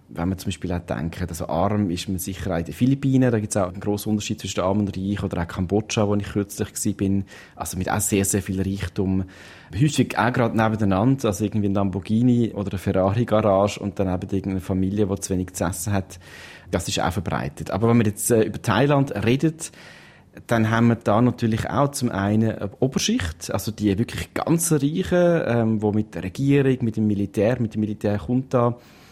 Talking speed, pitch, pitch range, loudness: 210 wpm, 105 Hz, 95-115 Hz, -22 LUFS